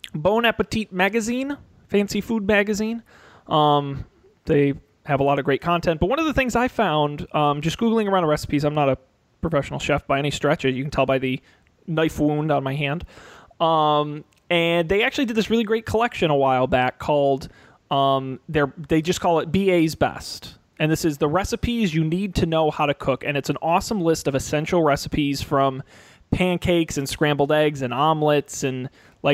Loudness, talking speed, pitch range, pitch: -22 LUFS, 190 wpm, 140-180 Hz, 150 Hz